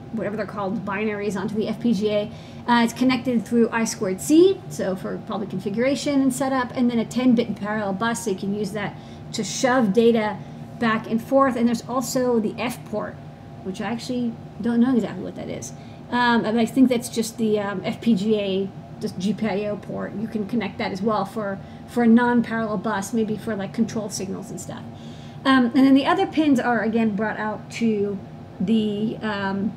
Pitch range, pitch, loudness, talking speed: 205-240 Hz, 220 Hz, -22 LUFS, 190 wpm